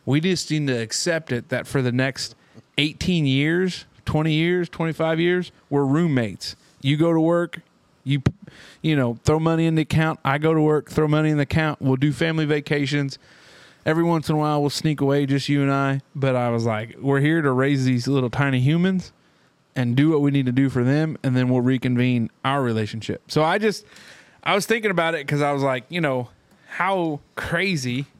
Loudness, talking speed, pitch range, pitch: -22 LUFS, 210 wpm, 130-160 Hz, 145 Hz